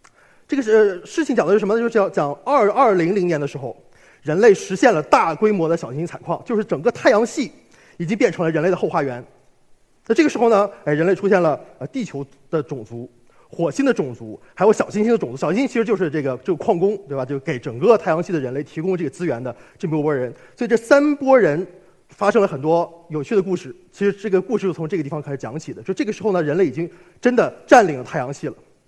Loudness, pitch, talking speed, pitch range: -19 LUFS, 185 Hz, 365 characters per minute, 155-220 Hz